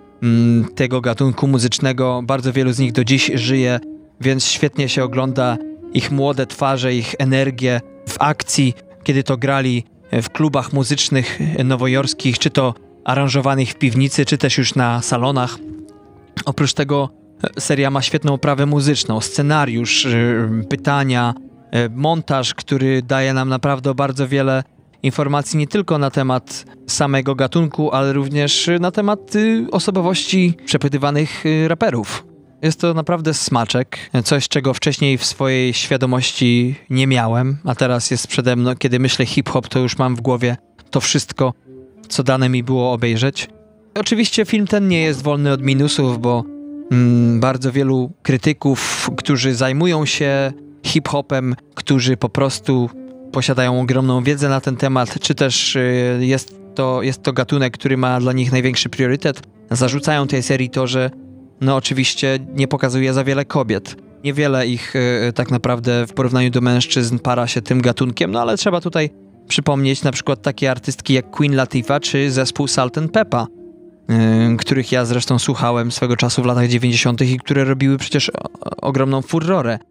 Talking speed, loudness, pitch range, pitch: 145 wpm, -17 LUFS, 125-145 Hz, 135 Hz